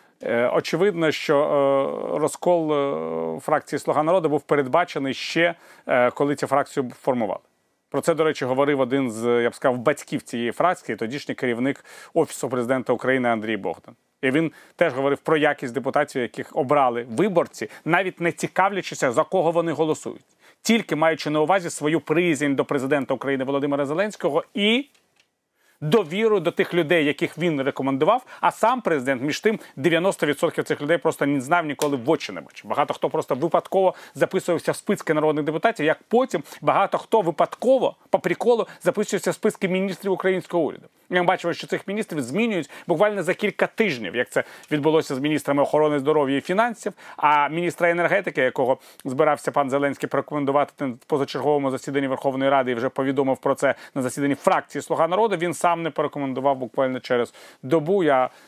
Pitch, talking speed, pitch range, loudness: 155 Hz, 160 wpm, 140-175 Hz, -23 LUFS